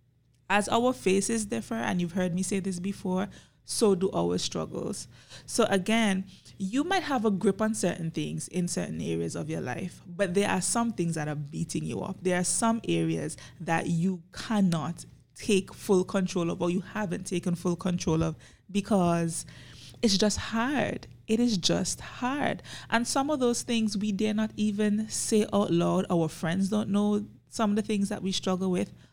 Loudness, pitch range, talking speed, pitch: -28 LUFS, 170-215 Hz, 185 wpm, 190 Hz